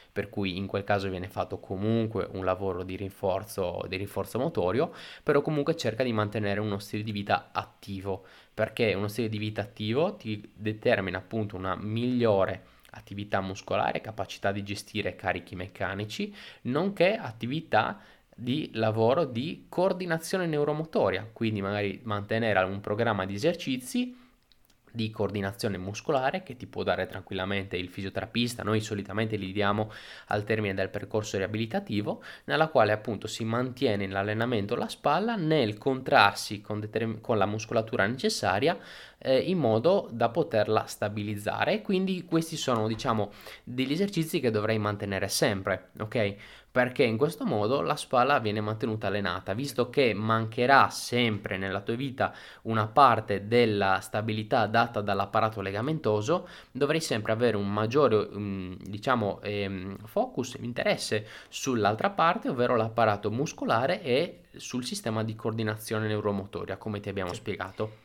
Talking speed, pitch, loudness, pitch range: 135 wpm, 110 Hz, -29 LUFS, 100-120 Hz